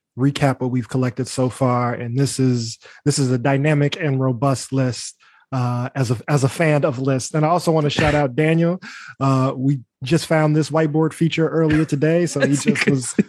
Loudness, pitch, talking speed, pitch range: -19 LUFS, 140 Hz, 205 wpm, 130-155 Hz